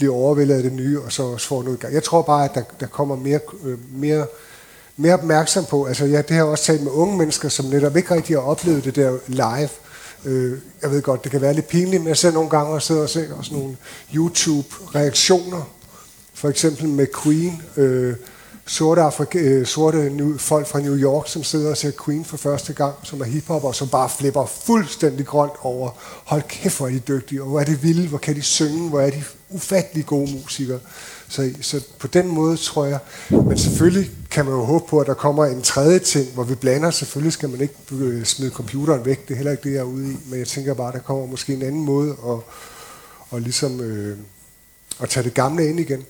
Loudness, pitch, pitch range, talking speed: -20 LUFS, 145 Hz, 135-155 Hz, 230 wpm